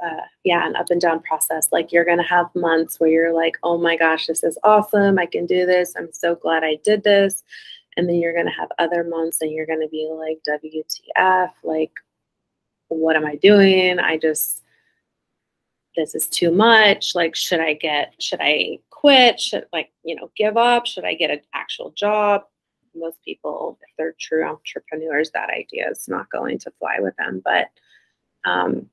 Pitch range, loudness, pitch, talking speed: 160-195 Hz, -18 LUFS, 170 Hz, 190 wpm